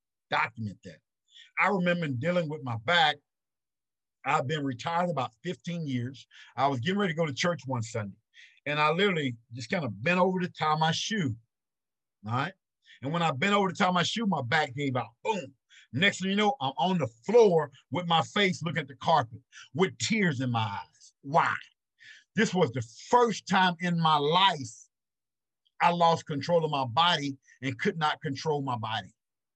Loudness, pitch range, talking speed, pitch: -28 LUFS, 130-180 Hz, 190 wpm, 155 Hz